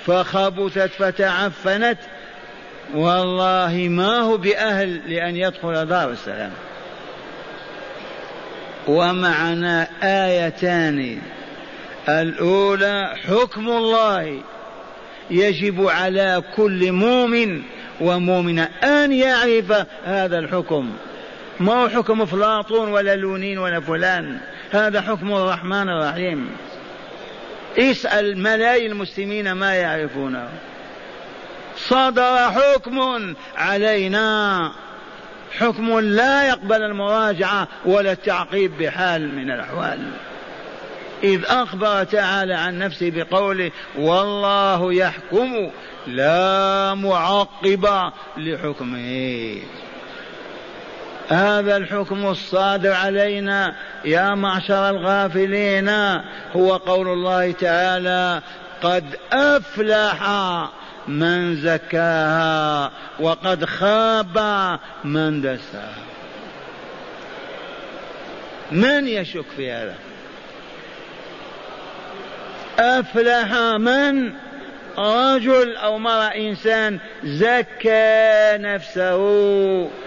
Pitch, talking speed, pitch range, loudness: 195 Hz, 70 wpm, 175-215 Hz, -19 LUFS